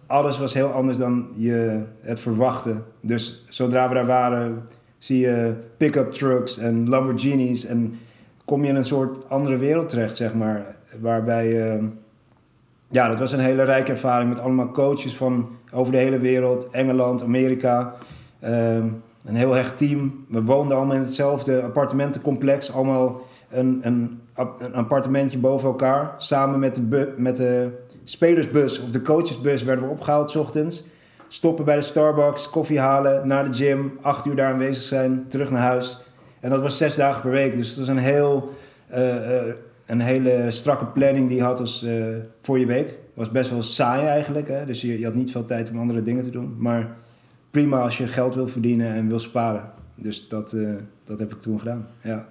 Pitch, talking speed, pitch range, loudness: 125 Hz, 185 wpm, 120-135 Hz, -22 LUFS